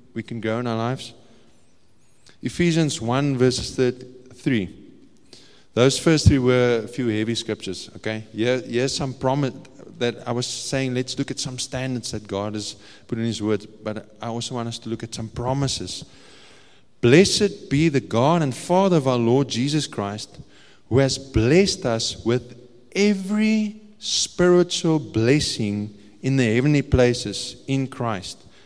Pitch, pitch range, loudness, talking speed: 125 Hz, 110-135 Hz, -22 LUFS, 155 wpm